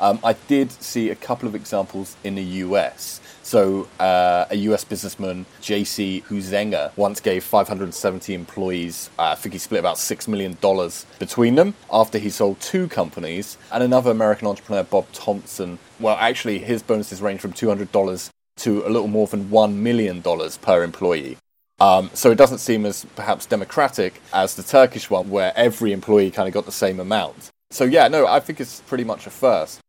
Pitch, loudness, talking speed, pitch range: 105 Hz, -20 LUFS, 180 wpm, 95-110 Hz